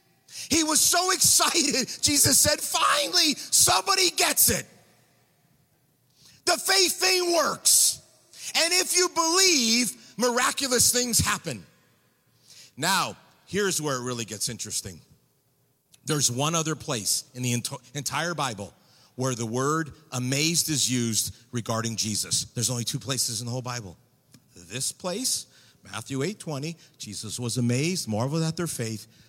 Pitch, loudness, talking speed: 140 Hz, -23 LUFS, 135 wpm